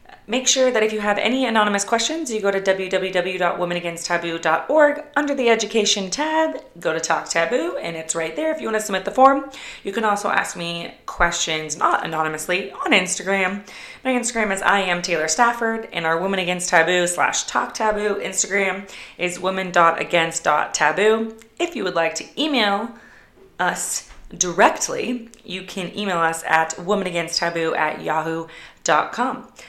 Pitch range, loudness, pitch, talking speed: 170-225 Hz, -20 LUFS, 195 Hz, 155 wpm